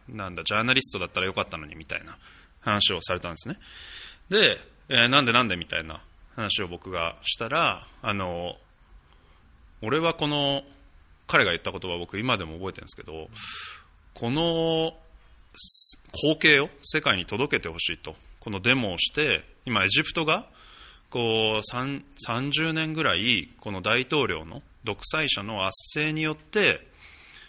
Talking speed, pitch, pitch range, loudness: 285 characters per minute, 105 Hz, 85-135 Hz, -25 LUFS